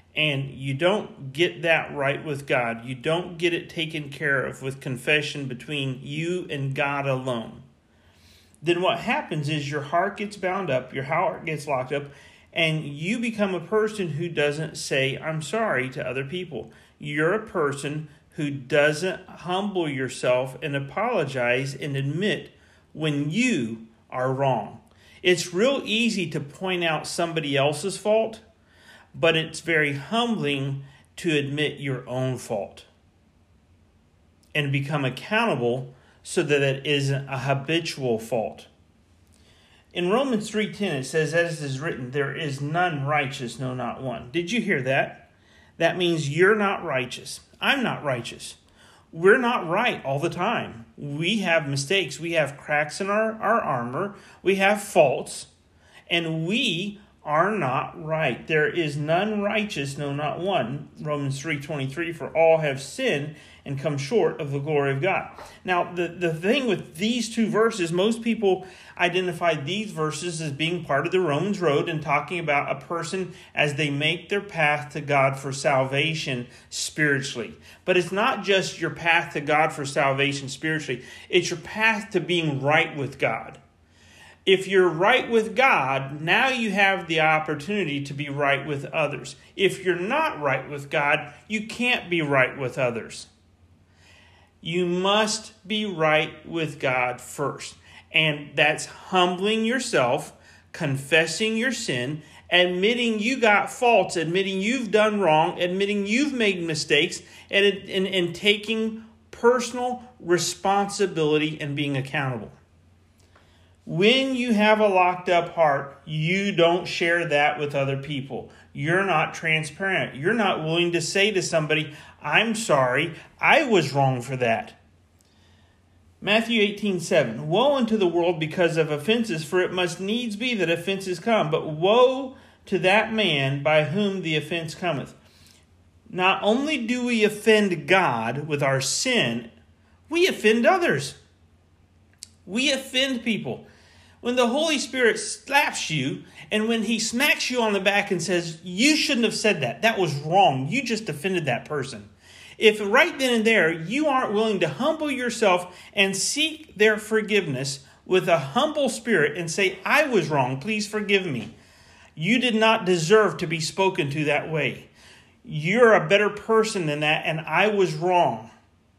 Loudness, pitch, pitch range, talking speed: -23 LUFS, 165 Hz, 140-200 Hz, 155 wpm